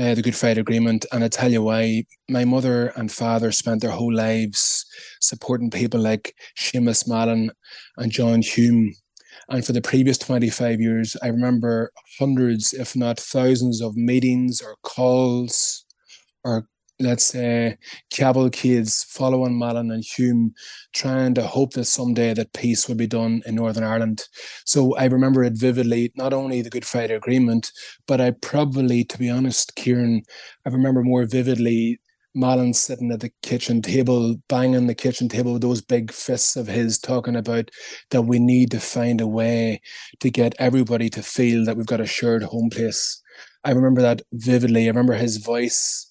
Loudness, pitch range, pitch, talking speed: -20 LUFS, 115-125 Hz, 120 Hz, 170 wpm